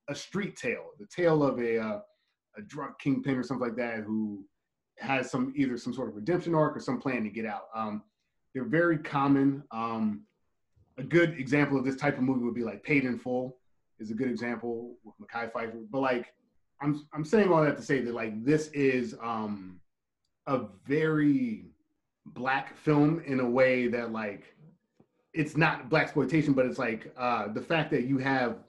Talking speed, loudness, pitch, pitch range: 190 wpm, -29 LUFS, 130 Hz, 115-150 Hz